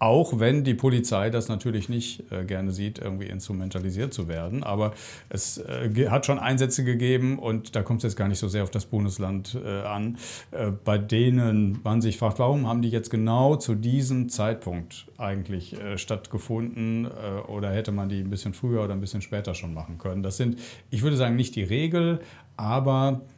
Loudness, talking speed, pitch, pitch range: -27 LUFS, 200 wpm, 110 Hz, 100-125 Hz